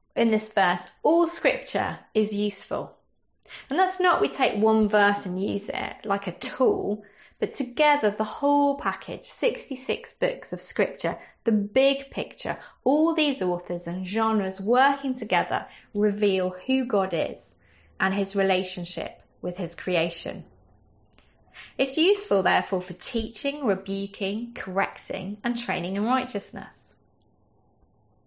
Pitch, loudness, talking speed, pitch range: 205 Hz, -26 LUFS, 125 wpm, 185-260 Hz